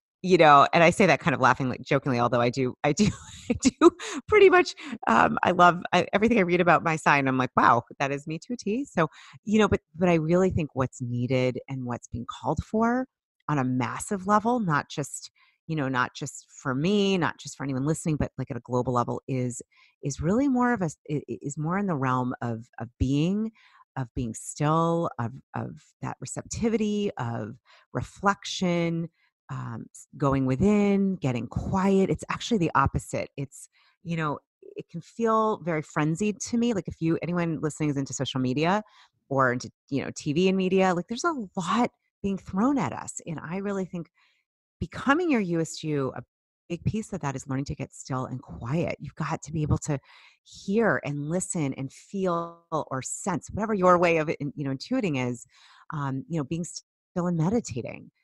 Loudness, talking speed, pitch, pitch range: -26 LUFS, 195 wpm, 160 Hz, 135-195 Hz